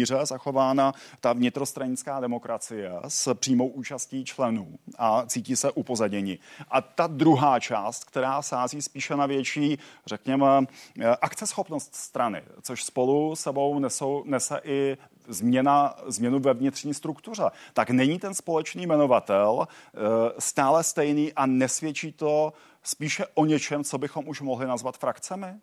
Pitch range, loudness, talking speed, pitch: 130-155 Hz, -26 LUFS, 125 wpm, 140 Hz